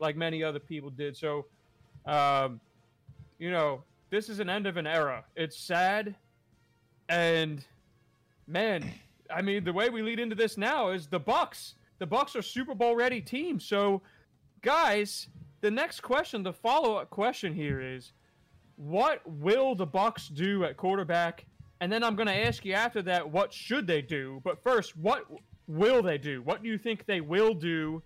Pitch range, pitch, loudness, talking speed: 150-210 Hz, 180 Hz, -30 LUFS, 175 wpm